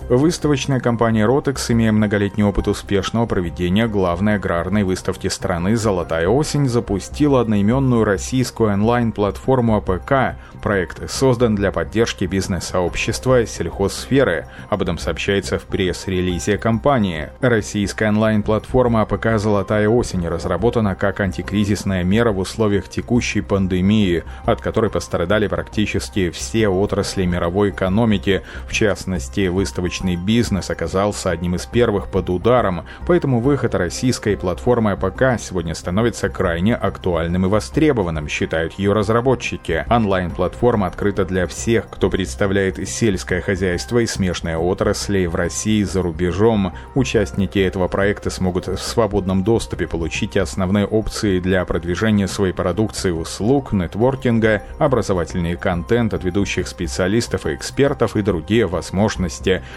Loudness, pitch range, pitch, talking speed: -19 LUFS, 90-115 Hz, 100 Hz, 120 wpm